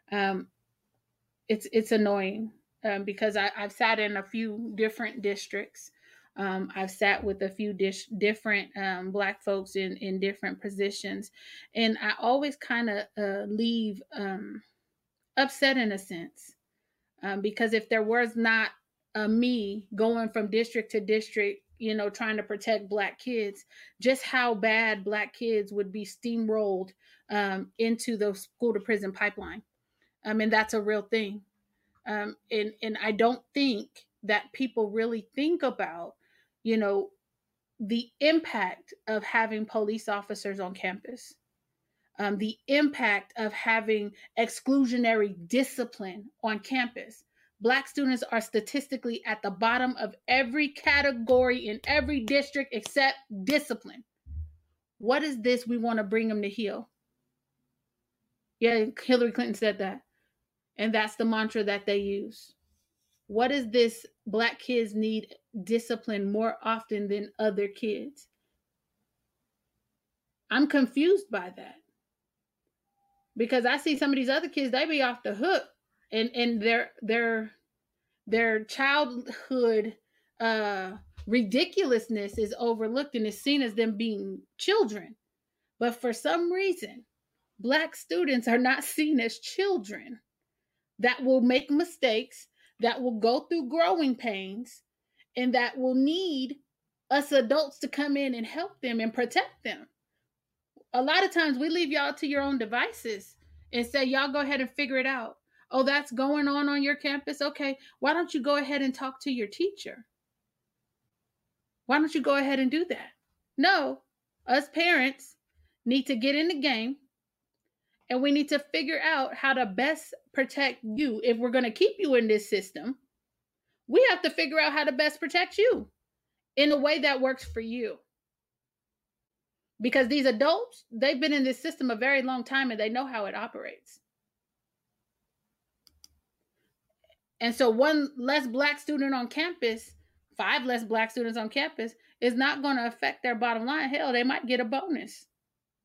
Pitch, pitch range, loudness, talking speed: 235 Hz, 215-275 Hz, -28 LUFS, 150 wpm